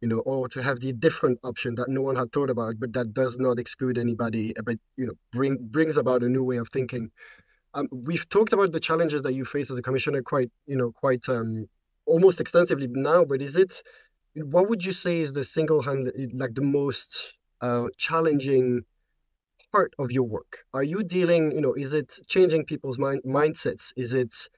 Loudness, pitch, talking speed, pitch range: -26 LUFS, 135 Hz, 205 wpm, 125-155 Hz